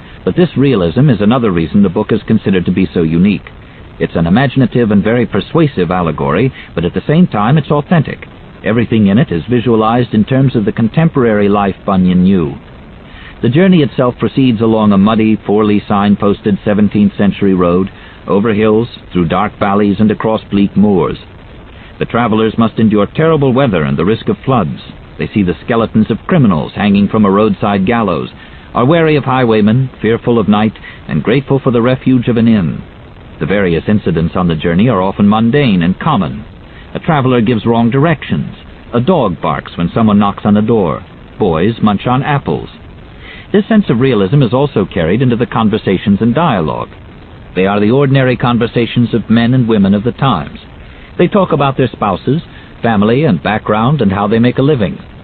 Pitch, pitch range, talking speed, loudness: 115 Hz, 100-130 Hz, 180 wpm, -11 LUFS